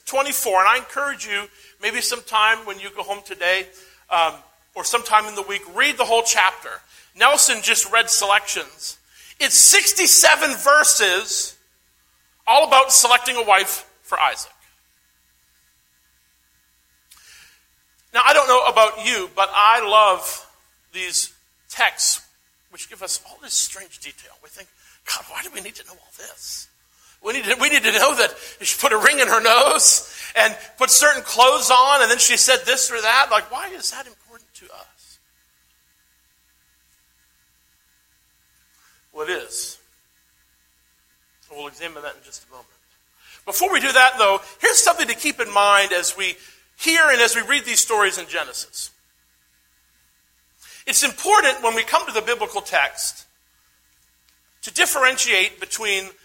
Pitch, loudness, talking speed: 190 Hz, -16 LUFS, 155 wpm